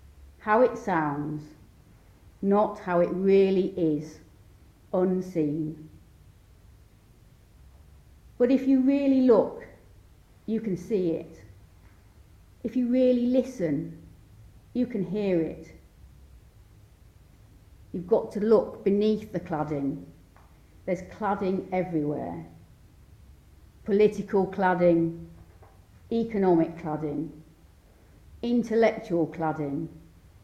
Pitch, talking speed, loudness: 155 Hz, 85 wpm, -26 LUFS